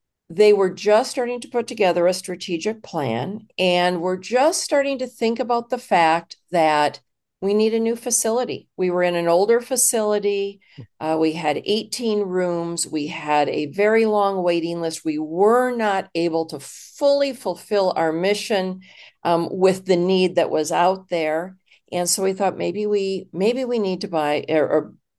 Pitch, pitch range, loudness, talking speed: 190 Hz, 170-215 Hz, -21 LUFS, 170 wpm